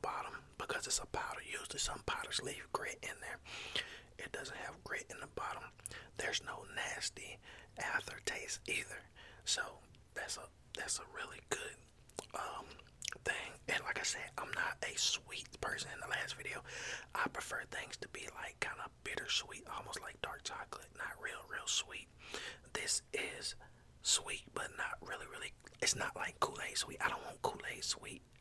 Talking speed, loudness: 170 wpm, -41 LUFS